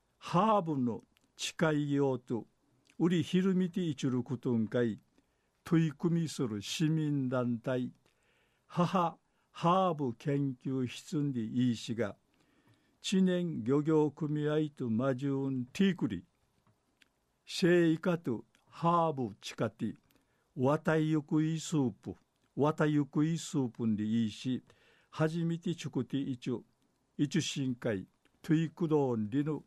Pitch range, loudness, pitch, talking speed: 125-160 Hz, -33 LUFS, 145 Hz, 245 characters per minute